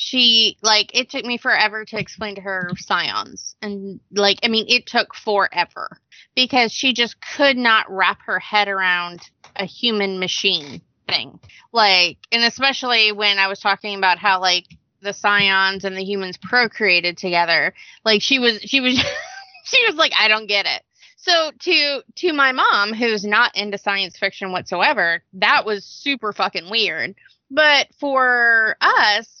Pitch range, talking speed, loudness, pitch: 195-245 Hz, 160 wpm, -17 LUFS, 210 Hz